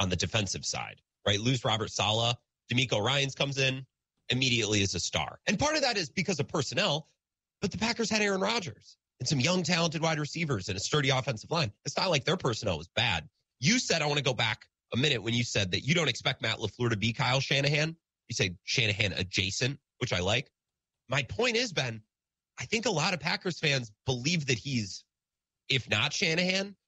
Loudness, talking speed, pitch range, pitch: -29 LUFS, 210 wpm, 110-160 Hz, 130 Hz